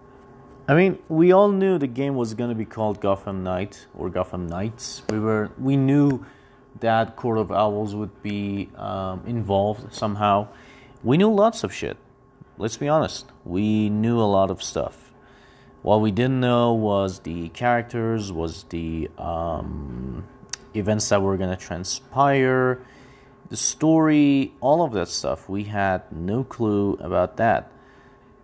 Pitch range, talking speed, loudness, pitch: 100-135 Hz, 150 wpm, -23 LUFS, 110 Hz